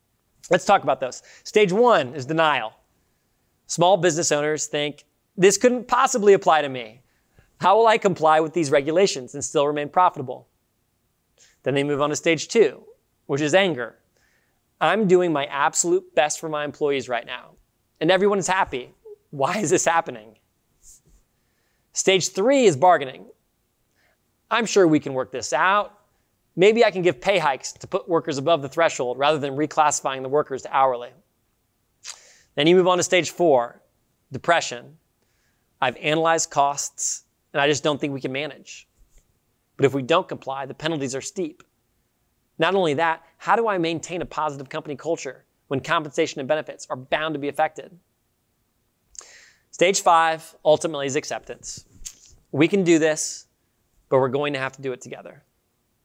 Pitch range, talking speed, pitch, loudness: 135-170 Hz, 165 wpm, 150 Hz, -21 LUFS